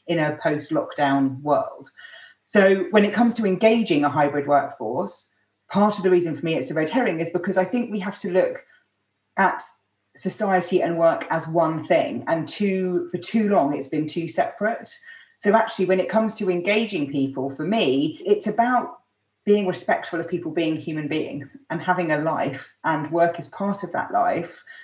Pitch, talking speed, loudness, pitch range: 180 Hz, 185 wpm, -22 LUFS, 160-210 Hz